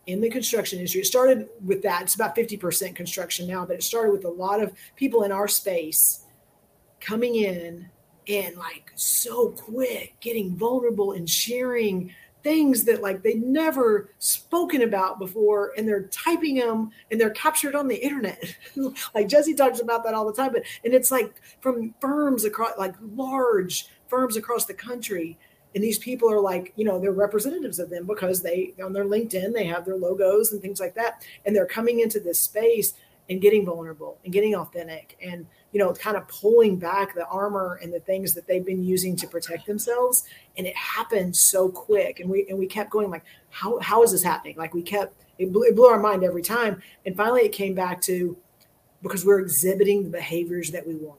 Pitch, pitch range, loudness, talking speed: 205 Hz, 185-230 Hz, -23 LUFS, 200 wpm